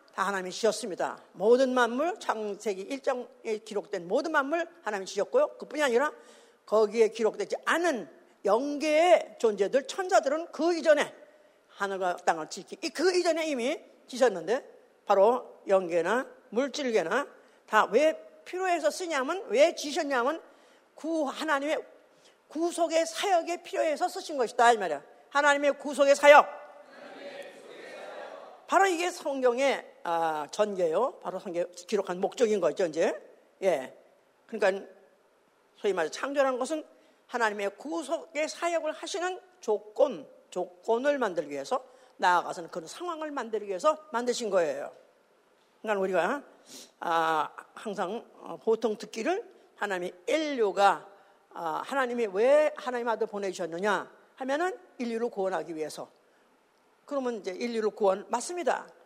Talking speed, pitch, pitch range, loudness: 295 characters per minute, 270 Hz, 210-325 Hz, -28 LUFS